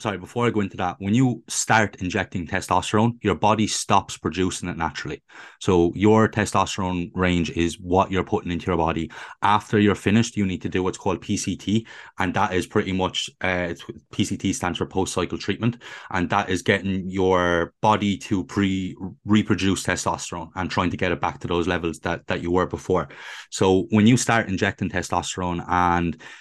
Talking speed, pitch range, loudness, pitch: 180 wpm, 90-105 Hz, -23 LUFS, 95 Hz